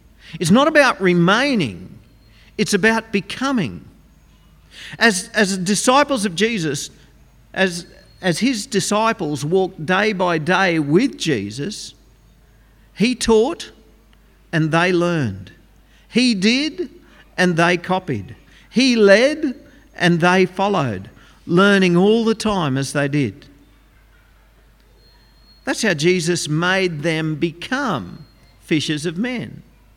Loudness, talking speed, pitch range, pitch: -18 LUFS, 105 wpm, 160-225 Hz, 185 Hz